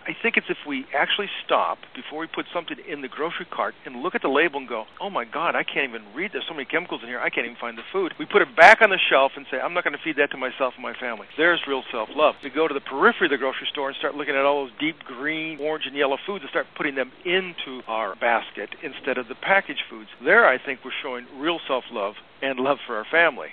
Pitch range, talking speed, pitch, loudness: 135-175 Hz, 285 wpm, 145 Hz, -23 LUFS